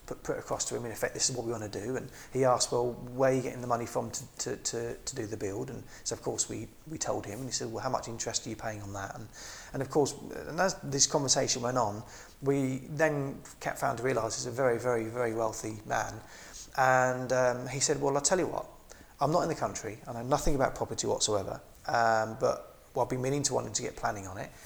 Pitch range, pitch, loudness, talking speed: 115-135 Hz, 125 Hz, -31 LUFS, 265 wpm